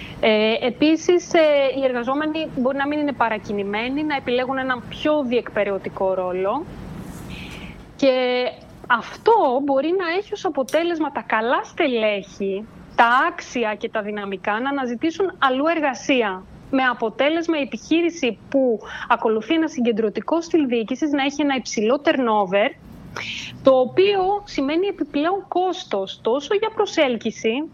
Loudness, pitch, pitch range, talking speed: -21 LUFS, 270 Hz, 225-315 Hz, 120 wpm